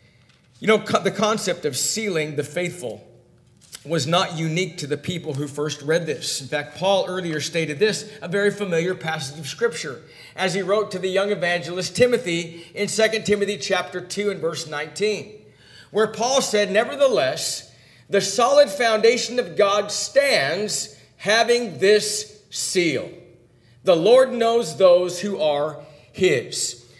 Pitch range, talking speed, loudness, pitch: 155-210 Hz, 145 wpm, -21 LUFS, 185 Hz